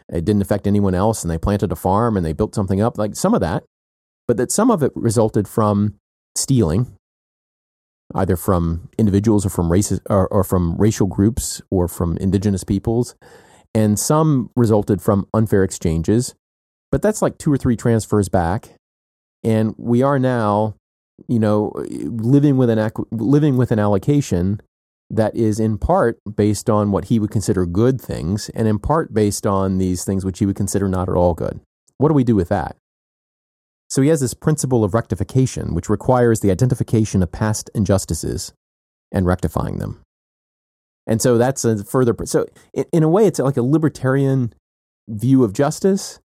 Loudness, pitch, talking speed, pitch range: -18 LUFS, 105 Hz, 175 wpm, 95-120 Hz